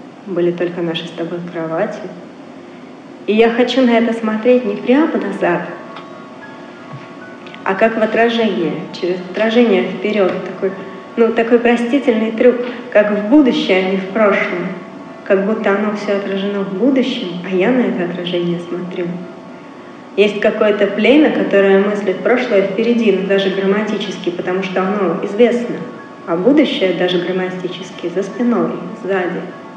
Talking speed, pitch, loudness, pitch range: 135 wpm, 200 Hz, -15 LUFS, 185-230 Hz